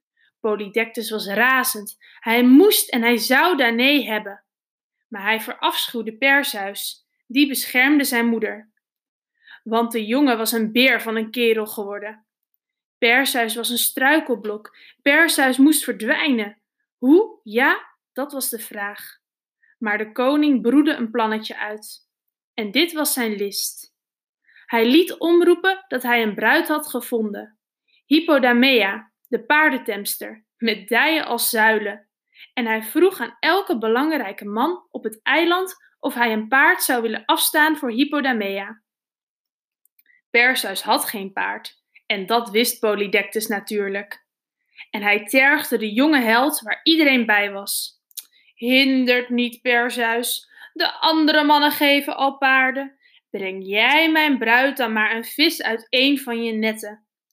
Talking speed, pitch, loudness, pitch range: 135 wpm, 240 Hz, -19 LUFS, 220-290 Hz